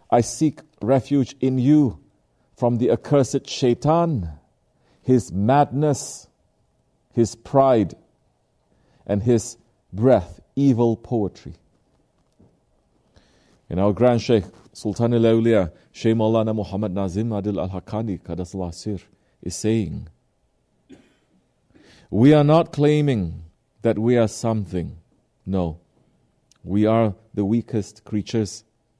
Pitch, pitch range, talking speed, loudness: 110 Hz, 100-125 Hz, 95 wpm, -21 LUFS